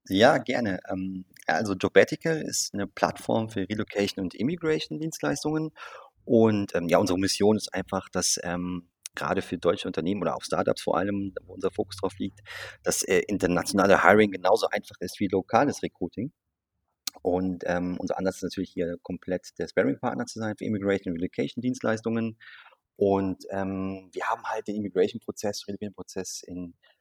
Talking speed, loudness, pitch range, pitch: 155 wpm, -27 LUFS, 90-110 Hz, 100 Hz